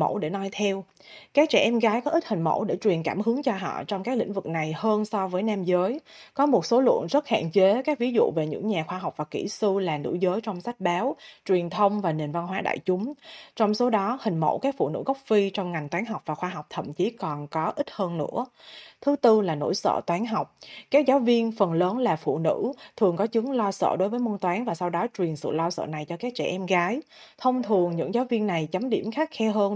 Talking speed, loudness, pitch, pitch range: 265 wpm, -26 LUFS, 205 Hz, 180-240 Hz